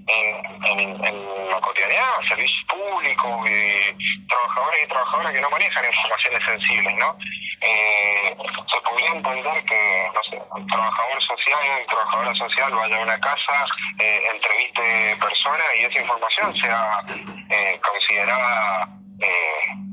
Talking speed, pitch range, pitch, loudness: 130 wpm, 105-115 Hz, 110 Hz, -19 LUFS